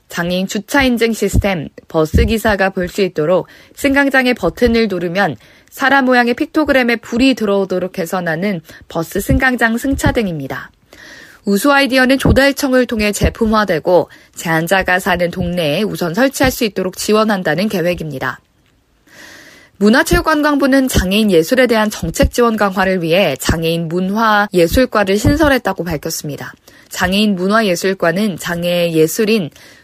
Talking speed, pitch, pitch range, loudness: 335 characters per minute, 200 Hz, 175-245 Hz, -14 LUFS